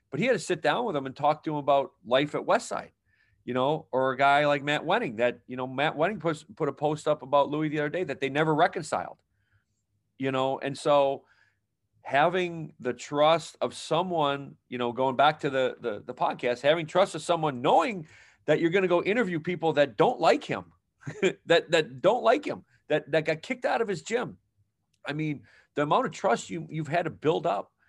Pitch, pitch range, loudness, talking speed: 150 Hz, 135-160 Hz, -27 LUFS, 220 wpm